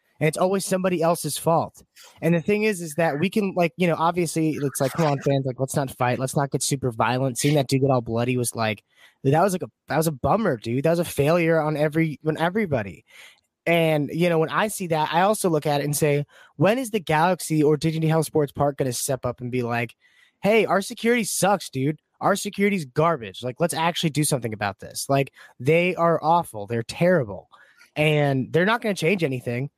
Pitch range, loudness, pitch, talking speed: 135-175 Hz, -23 LUFS, 155 Hz, 230 wpm